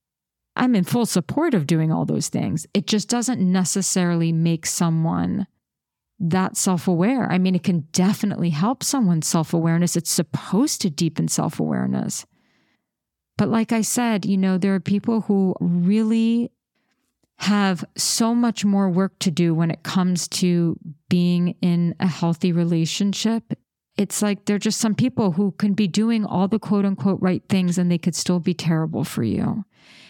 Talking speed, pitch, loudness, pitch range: 170 wpm, 190 Hz, -21 LUFS, 175-210 Hz